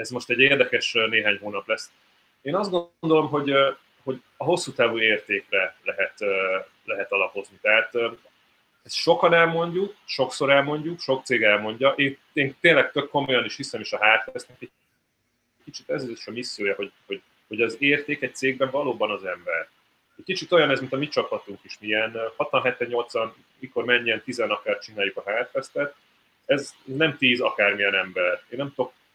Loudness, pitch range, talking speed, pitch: -23 LUFS, 120-175 Hz, 165 wpm, 140 Hz